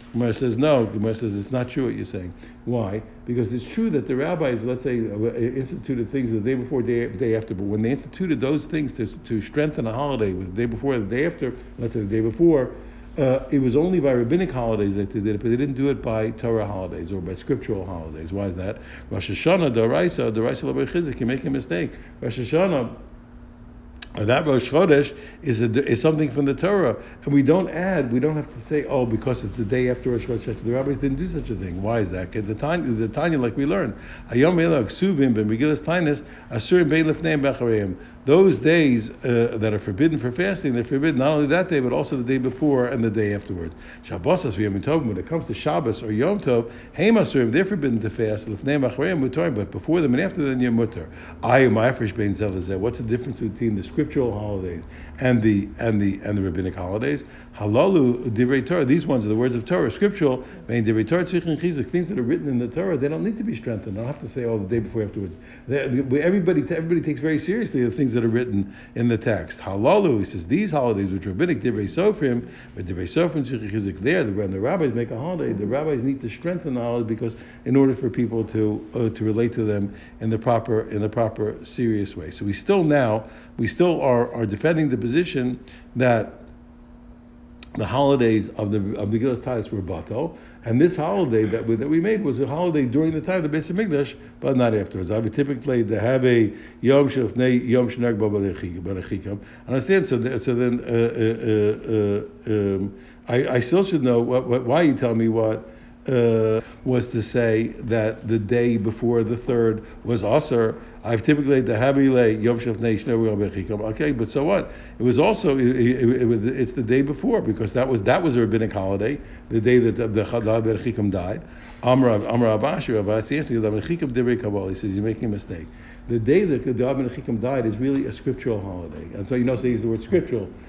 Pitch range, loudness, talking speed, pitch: 110-140 Hz, -22 LUFS, 210 wpm, 120 Hz